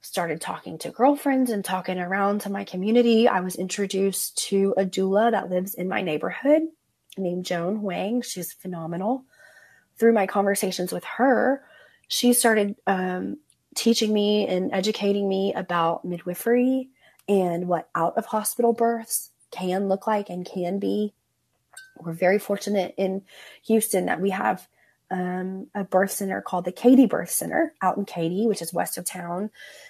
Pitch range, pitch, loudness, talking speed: 185-230 Hz, 200 Hz, -24 LUFS, 155 wpm